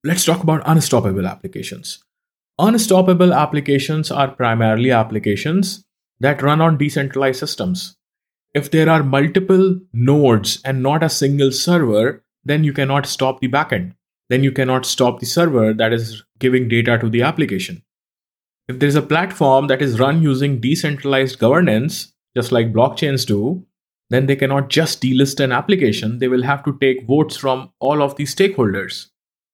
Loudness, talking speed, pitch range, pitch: -16 LUFS, 155 wpm, 125-160 Hz, 140 Hz